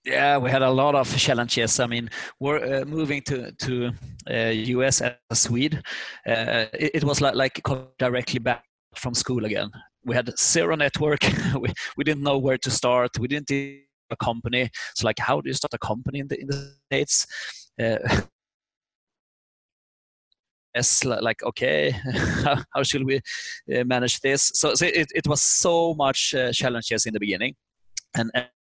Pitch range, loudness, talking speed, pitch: 120-140 Hz, -23 LUFS, 175 wpm, 130 Hz